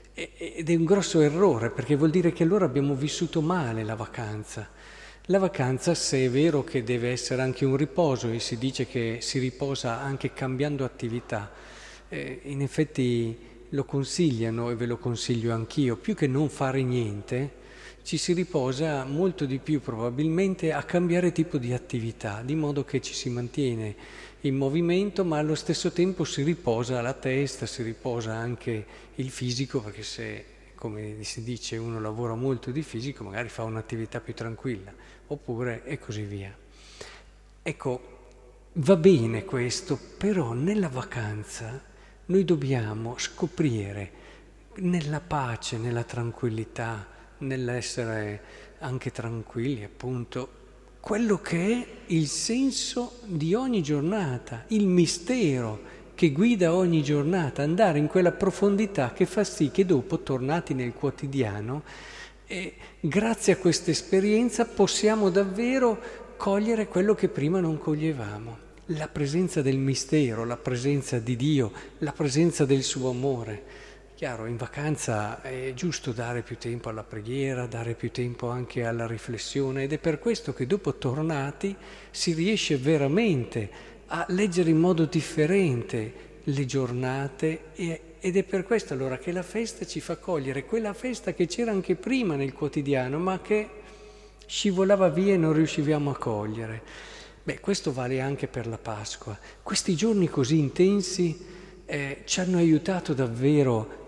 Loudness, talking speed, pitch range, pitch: -27 LUFS, 145 wpm, 120-175 Hz, 140 Hz